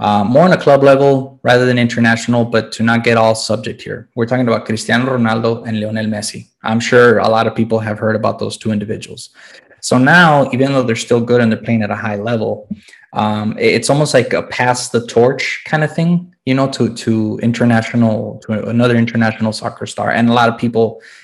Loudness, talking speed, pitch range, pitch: -14 LUFS, 215 wpm, 110-125 Hz, 115 Hz